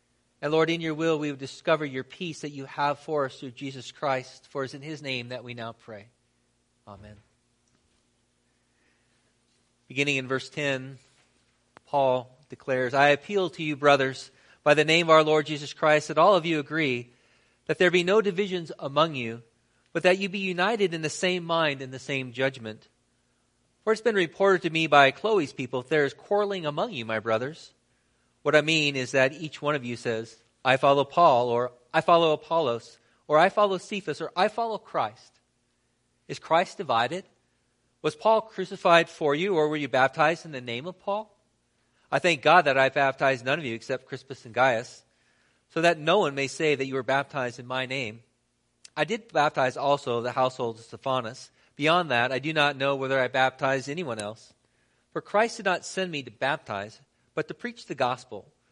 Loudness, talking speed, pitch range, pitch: -25 LUFS, 195 wpm, 125-160 Hz, 140 Hz